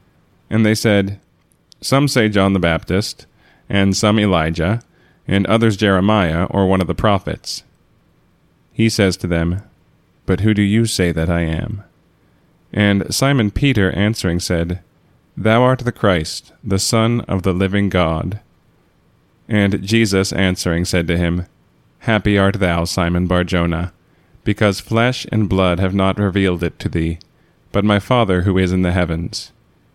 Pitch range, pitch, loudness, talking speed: 90-105 Hz, 95 Hz, -17 LUFS, 150 wpm